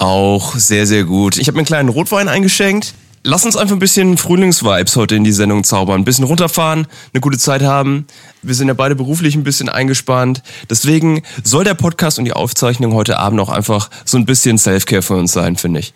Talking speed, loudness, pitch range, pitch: 215 wpm, -12 LUFS, 105-155 Hz, 130 Hz